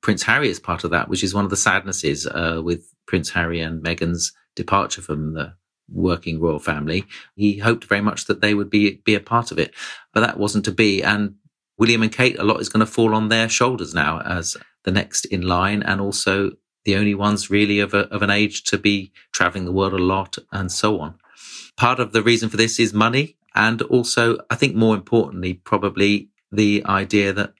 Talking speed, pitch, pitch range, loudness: 215 wpm, 100 Hz, 95-110 Hz, -20 LUFS